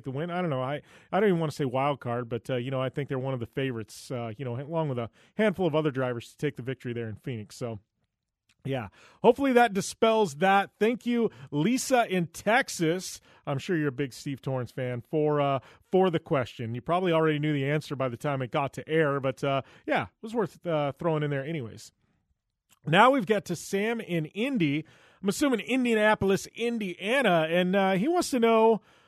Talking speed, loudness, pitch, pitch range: 220 wpm, -28 LUFS, 155 Hz, 130-195 Hz